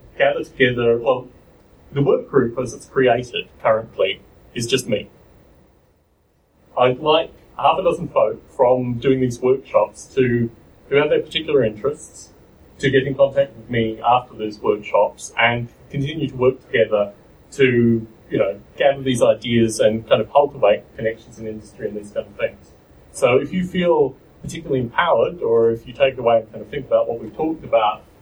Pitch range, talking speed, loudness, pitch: 115-140 Hz, 175 wpm, -19 LUFS, 125 Hz